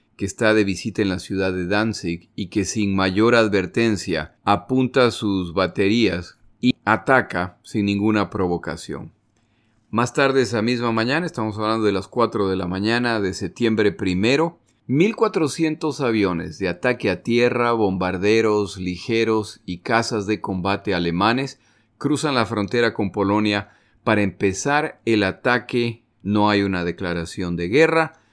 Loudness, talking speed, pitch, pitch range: -21 LUFS, 140 wpm, 110 Hz, 95-120 Hz